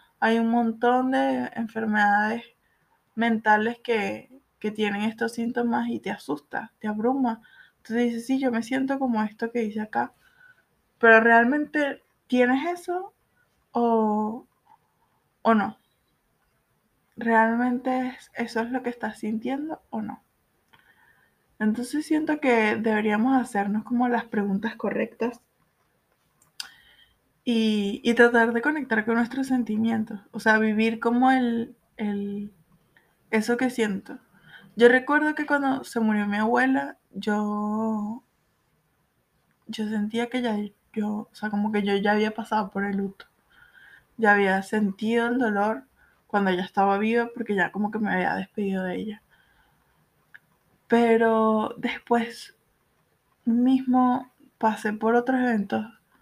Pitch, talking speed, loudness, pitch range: 230 Hz, 125 wpm, -24 LUFS, 215-250 Hz